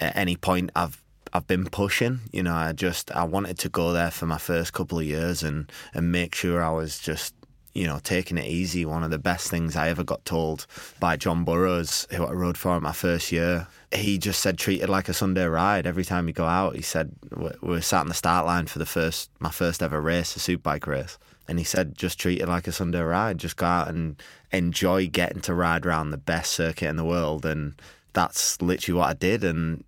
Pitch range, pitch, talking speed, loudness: 80-90 Hz, 85 Hz, 240 wpm, -26 LUFS